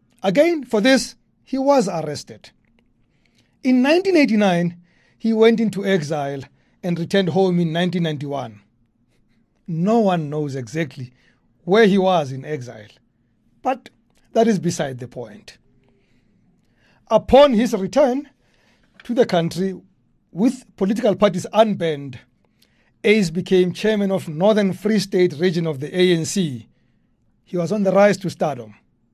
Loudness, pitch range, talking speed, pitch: -19 LUFS, 155-220 Hz, 125 wpm, 185 Hz